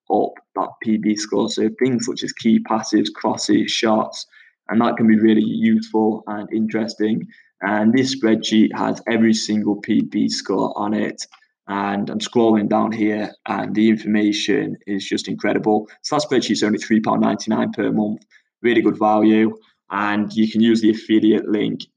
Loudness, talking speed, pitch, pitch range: -19 LUFS, 160 wpm, 110 Hz, 105-110 Hz